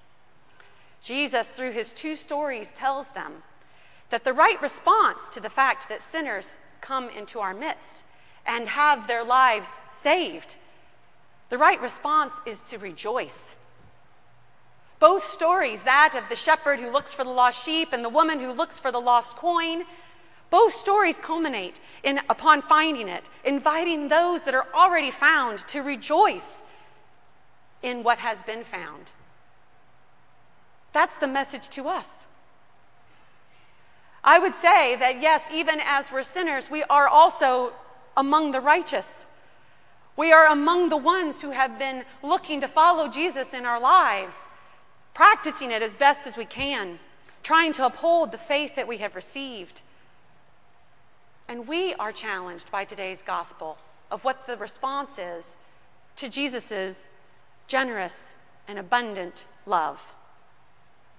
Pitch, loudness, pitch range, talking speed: 275 Hz, -23 LUFS, 240-315 Hz, 140 wpm